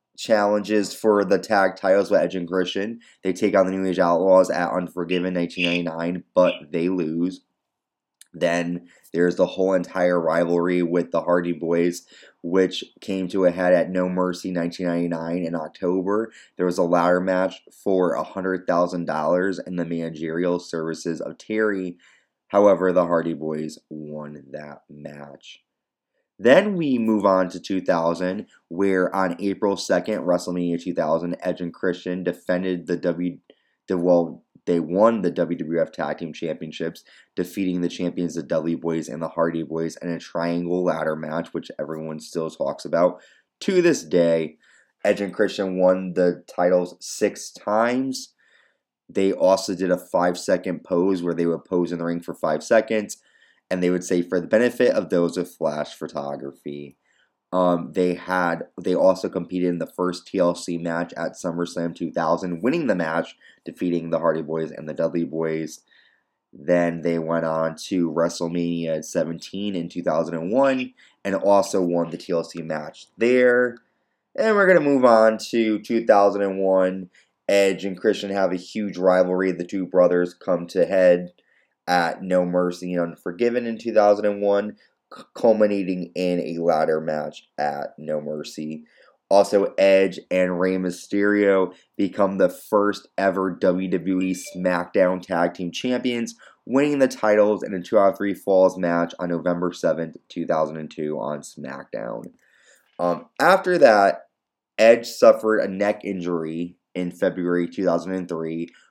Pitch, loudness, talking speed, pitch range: 90 Hz, -22 LUFS, 150 wpm, 85-95 Hz